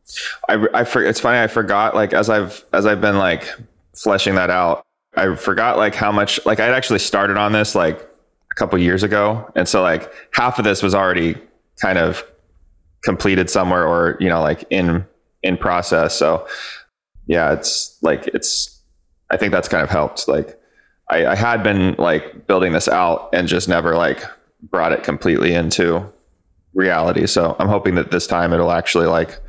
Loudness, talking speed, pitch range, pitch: -17 LUFS, 185 wpm, 85-105 Hz, 90 Hz